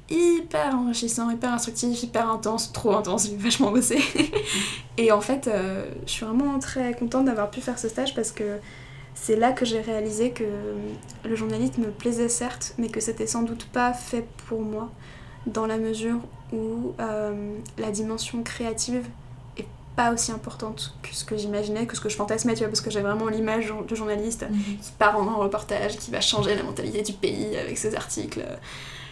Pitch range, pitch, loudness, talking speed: 210-240 Hz, 225 Hz, -26 LUFS, 190 wpm